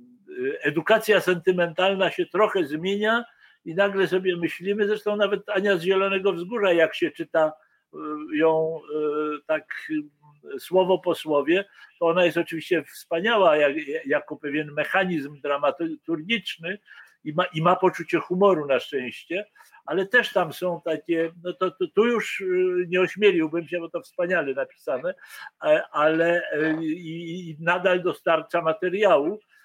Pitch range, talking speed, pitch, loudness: 160-200 Hz, 120 wpm, 180 Hz, -24 LUFS